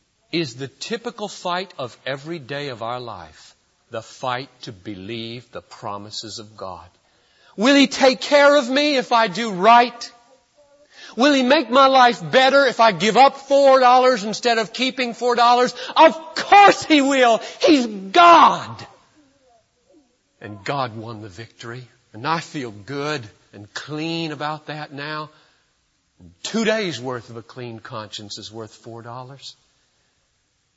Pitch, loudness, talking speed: 170 Hz, -17 LUFS, 150 wpm